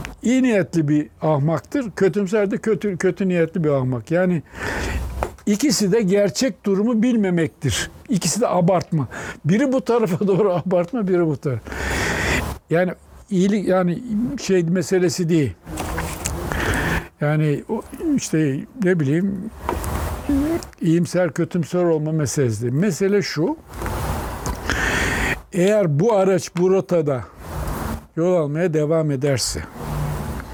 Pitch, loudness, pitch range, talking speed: 175 Hz, -21 LUFS, 140-200 Hz, 105 wpm